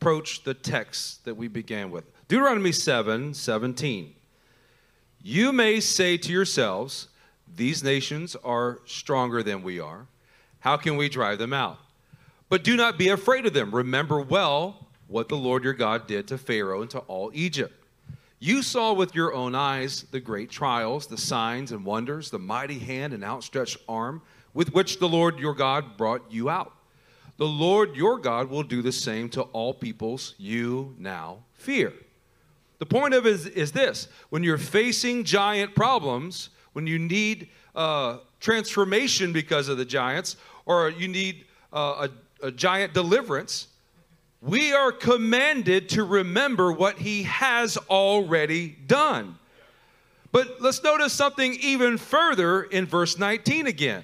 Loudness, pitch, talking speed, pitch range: -25 LUFS, 160 Hz, 155 wpm, 130-200 Hz